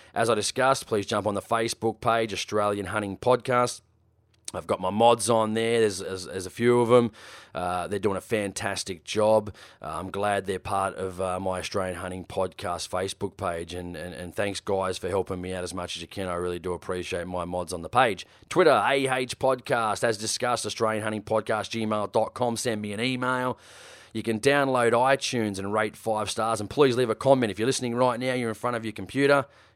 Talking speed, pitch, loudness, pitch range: 210 wpm, 110 Hz, -26 LUFS, 95-120 Hz